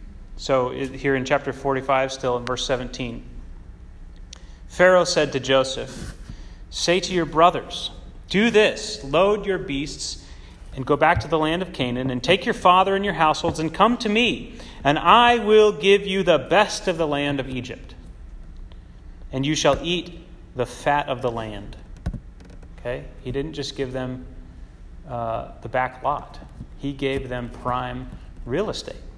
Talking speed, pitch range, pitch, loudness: 160 wpm, 115-170 Hz, 135 Hz, -21 LUFS